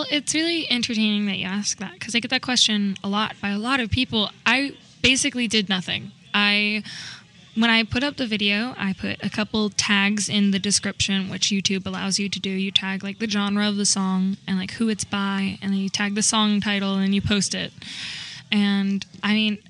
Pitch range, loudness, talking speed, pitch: 195-220 Hz, -22 LUFS, 215 wpm, 205 Hz